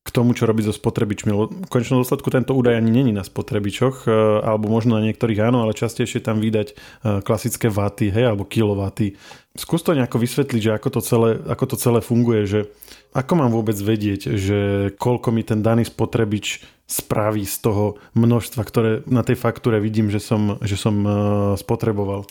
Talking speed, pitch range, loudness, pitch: 180 wpm, 105-120 Hz, -20 LUFS, 110 Hz